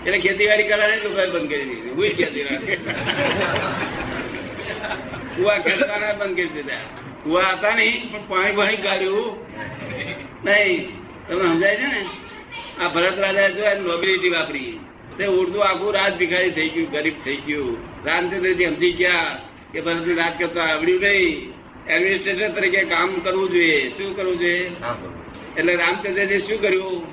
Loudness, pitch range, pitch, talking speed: -20 LUFS, 170-200 Hz, 185 Hz, 145 wpm